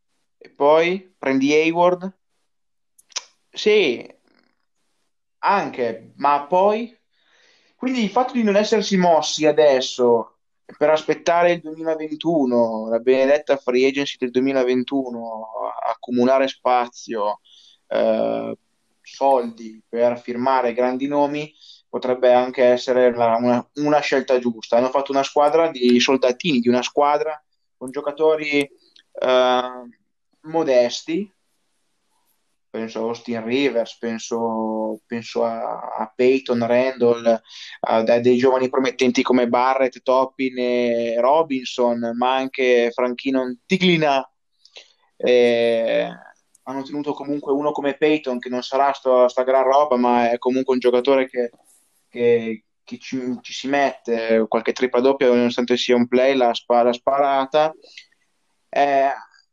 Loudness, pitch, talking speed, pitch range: -19 LUFS, 130 Hz, 115 wpm, 120-145 Hz